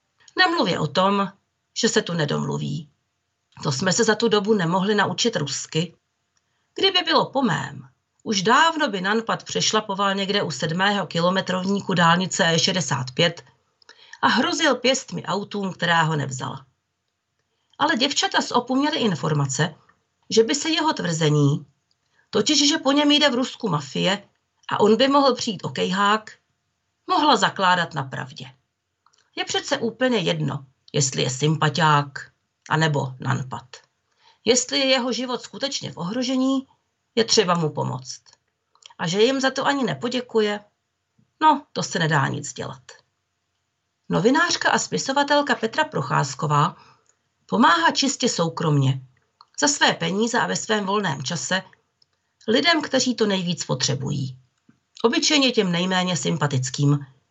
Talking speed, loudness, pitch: 130 wpm, -21 LUFS, 195 Hz